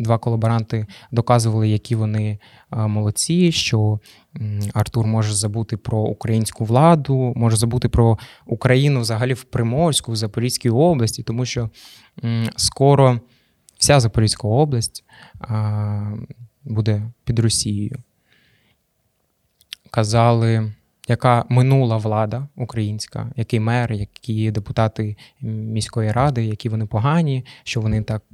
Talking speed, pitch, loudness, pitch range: 105 wpm, 115 Hz, -19 LUFS, 110-125 Hz